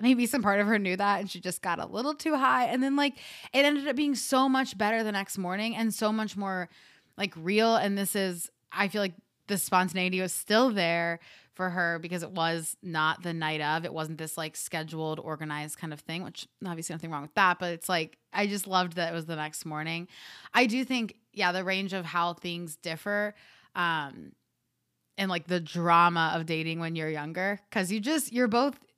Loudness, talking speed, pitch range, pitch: -29 LUFS, 220 wpm, 165-215 Hz, 185 Hz